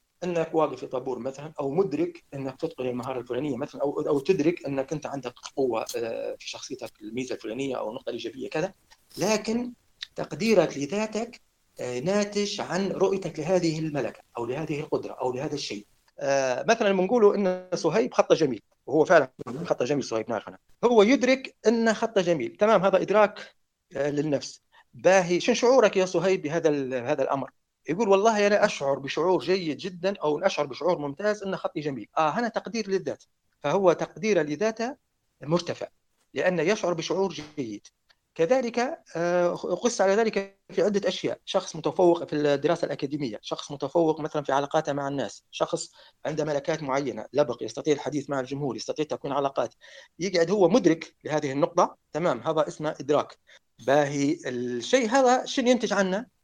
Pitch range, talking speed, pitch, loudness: 145-205 Hz, 150 wpm, 170 Hz, -26 LUFS